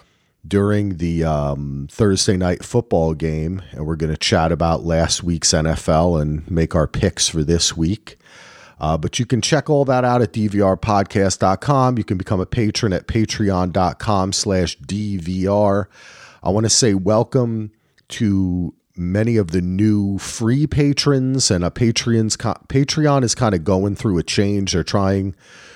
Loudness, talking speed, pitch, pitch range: -18 LUFS, 155 wpm, 100 Hz, 85-110 Hz